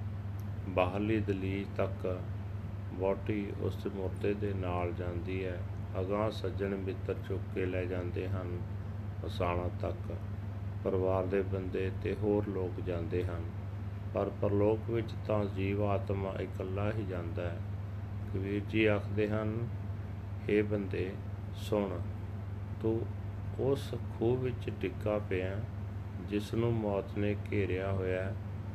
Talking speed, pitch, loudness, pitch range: 120 wpm, 100 Hz, -35 LUFS, 95-100 Hz